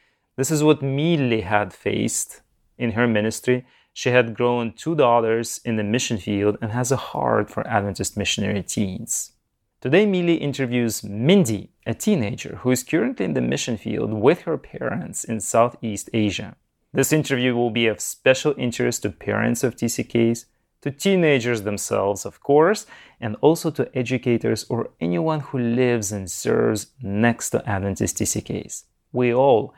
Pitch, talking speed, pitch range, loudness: 120 Hz, 155 wpm, 110-130 Hz, -22 LUFS